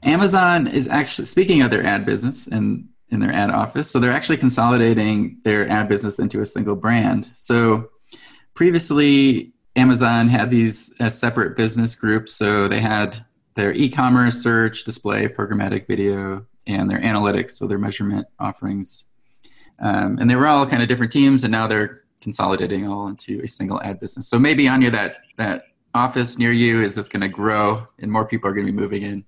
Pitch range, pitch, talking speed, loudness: 105-125 Hz, 115 Hz, 185 wpm, -19 LUFS